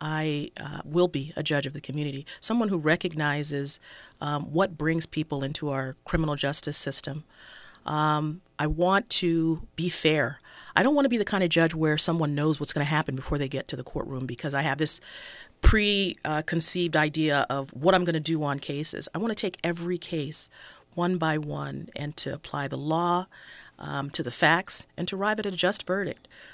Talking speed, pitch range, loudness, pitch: 200 wpm, 145-175 Hz, -26 LUFS, 155 Hz